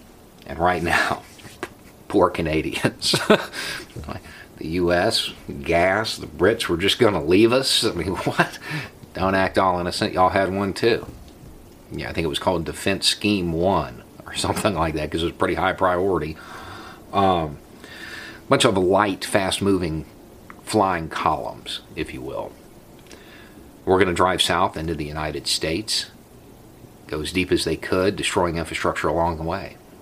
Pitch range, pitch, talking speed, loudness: 80-95 Hz, 90 Hz, 150 wpm, -22 LUFS